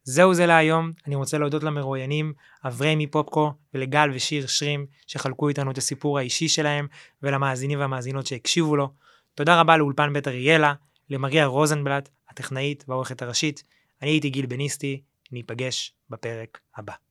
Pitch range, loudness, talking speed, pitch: 135-150 Hz, -23 LUFS, 135 wpm, 145 Hz